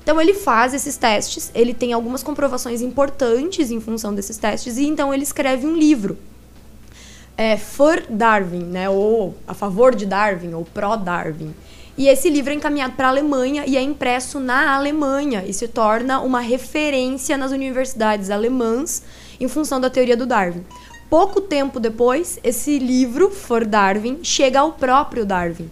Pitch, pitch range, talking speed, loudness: 255 Hz, 225-280 Hz, 165 wpm, -18 LUFS